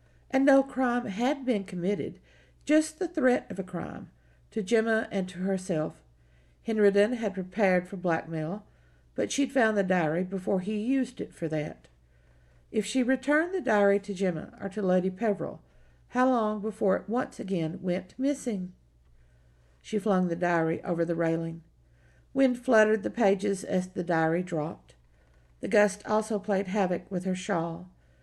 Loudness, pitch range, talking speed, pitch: -28 LUFS, 165-220 Hz, 160 wpm, 195 Hz